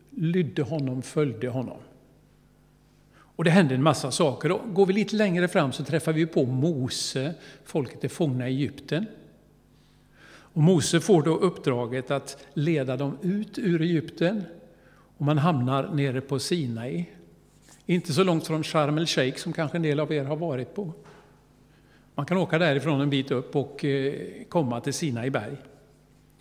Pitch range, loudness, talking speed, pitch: 135-170 Hz, -26 LUFS, 155 wpm, 150 Hz